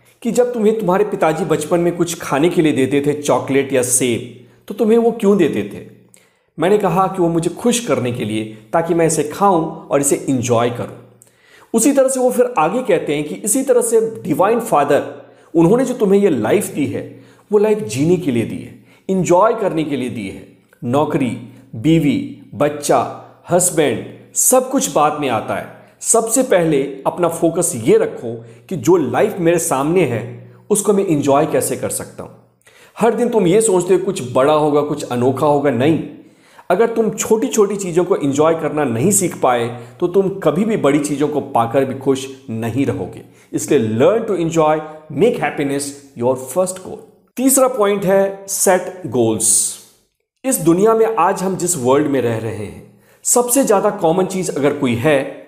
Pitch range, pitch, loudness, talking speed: 135-200 Hz, 165 Hz, -16 LUFS, 185 wpm